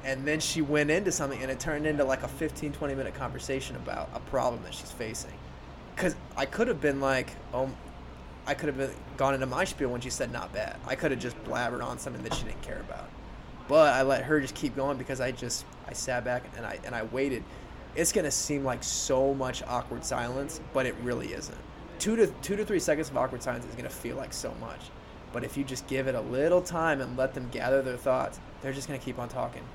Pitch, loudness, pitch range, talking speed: 135 Hz, -31 LUFS, 125-145 Hz, 240 wpm